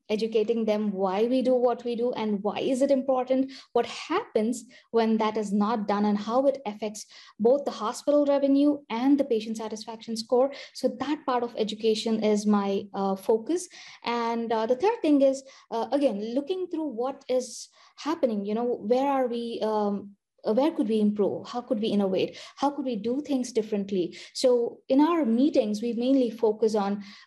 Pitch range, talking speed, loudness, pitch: 215-270 Hz, 185 wpm, -26 LUFS, 235 Hz